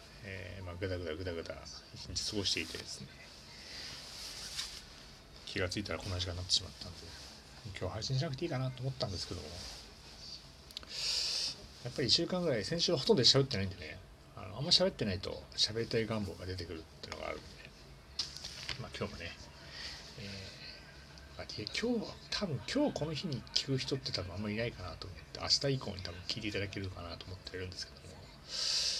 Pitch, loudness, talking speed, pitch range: 90 Hz, -36 LUFS, 385 characters per minute, 75-110 Hz